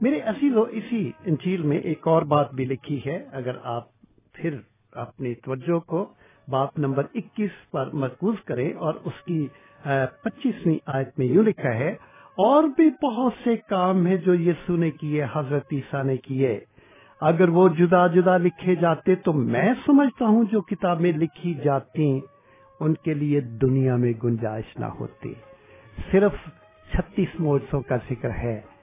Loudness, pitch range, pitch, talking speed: -23 LUFS, 135-185 Hz, 160 Hz, 155 wpm